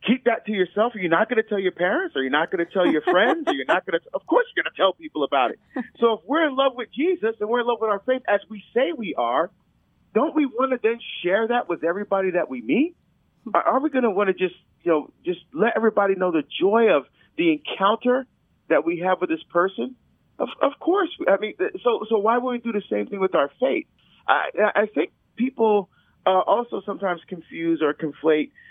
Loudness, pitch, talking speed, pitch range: -23 LUFS, 215 Hz, 245 wpm, 180-255 Hz